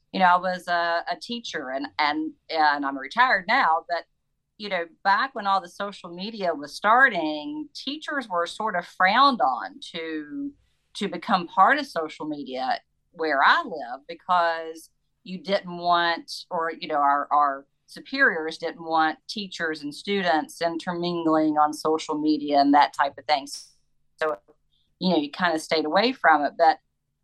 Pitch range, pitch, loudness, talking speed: 150-185 Hz, 165 Hz, -24 LUFS, 165 wpm